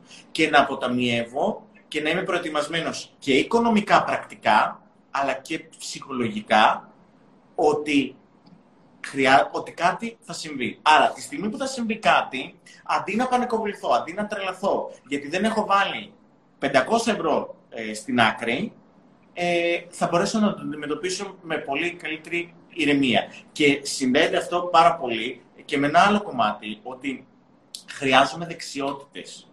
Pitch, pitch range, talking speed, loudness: 170 Hz, 140-205 Hz, 130 wpm, -23 LUFS